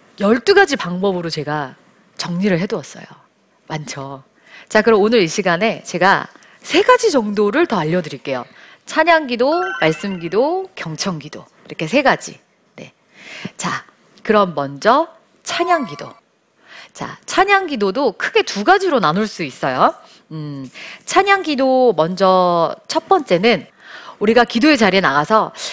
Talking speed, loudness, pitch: 260 characters per minute, -16 LUFS, 210 Hz